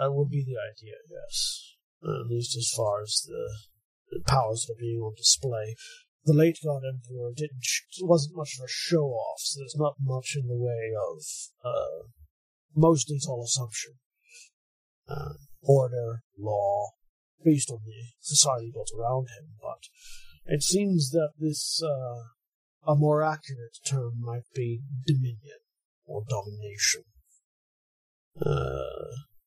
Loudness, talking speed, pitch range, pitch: -28 LUFS, 145 wpm, 115-150 Hz, 130 Hz